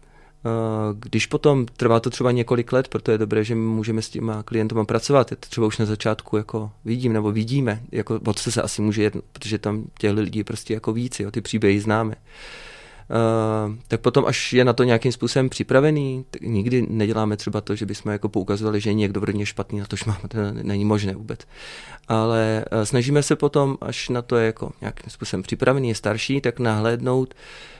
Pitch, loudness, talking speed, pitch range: 110 Hz, -22 LUFS, 190 wpm, 105-125 Hz